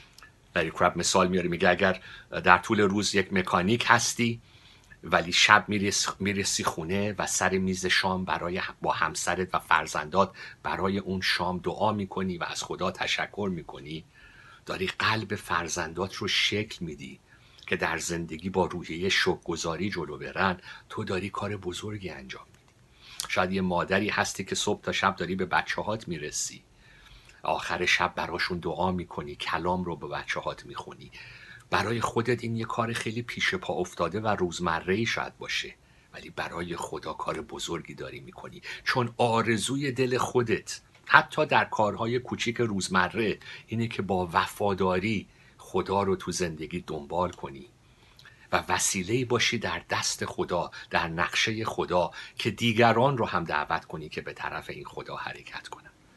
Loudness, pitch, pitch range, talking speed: -28 LUFS, 100 Hz, 90-115 Hz, 150 wpm